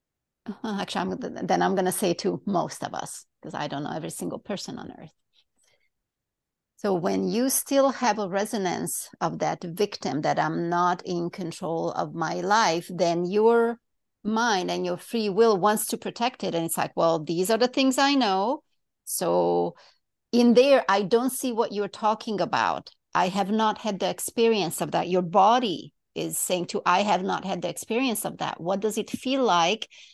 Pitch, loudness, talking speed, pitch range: 205 Hz, -25 LUFS, 190 wpm, 180-230 Hz